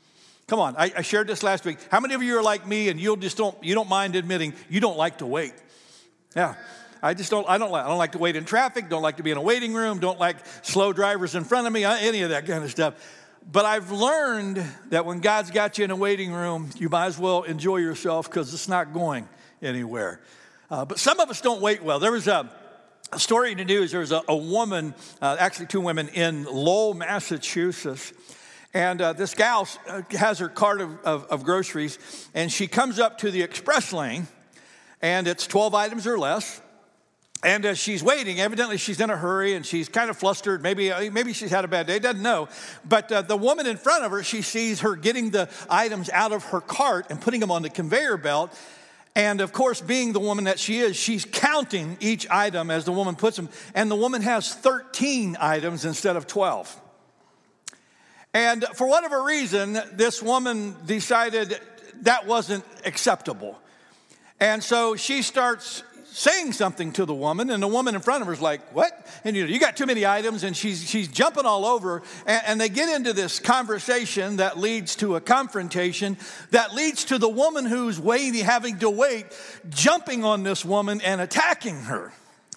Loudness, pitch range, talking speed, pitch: -24 LUFS, 180-230 Hz, 210 wpm, 205 Hz